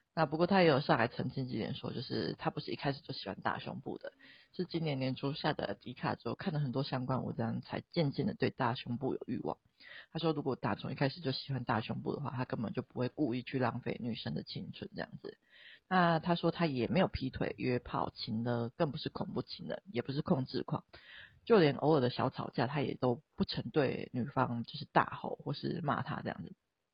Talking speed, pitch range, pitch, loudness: 325 characters per minute, 120-160 Hz, 135 Hz, -36 LUFS